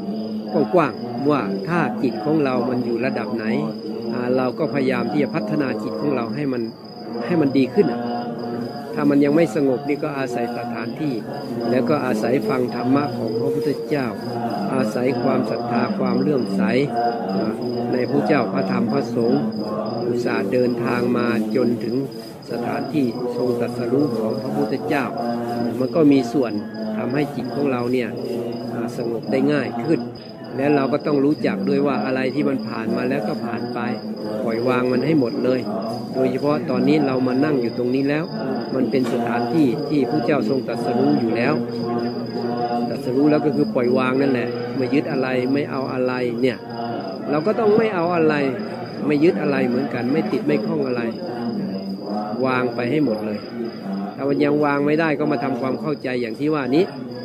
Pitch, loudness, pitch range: 125 Hz, -21 LUFS, 120-140 Hz